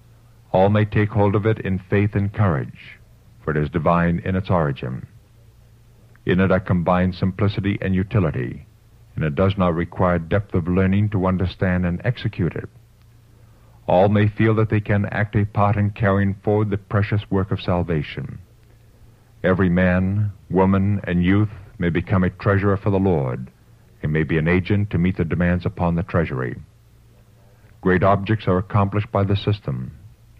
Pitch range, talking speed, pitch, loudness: 90-110 Hz, 170 wpm, 100 Hz, -20 LUFS